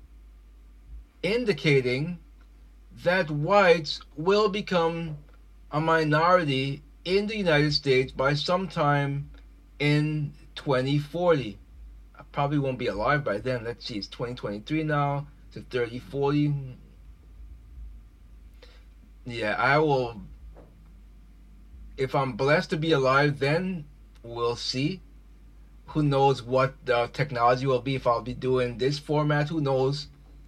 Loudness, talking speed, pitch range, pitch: -26 LUFS, 110 wpm, 120-150 Hz, 135 Hz